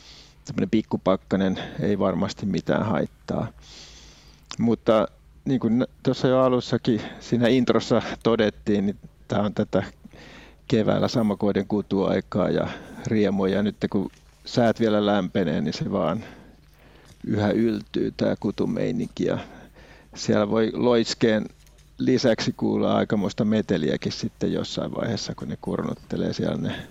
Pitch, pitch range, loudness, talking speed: 105 Hz, 100-115 Hz, -24 LUFS, 115 wpm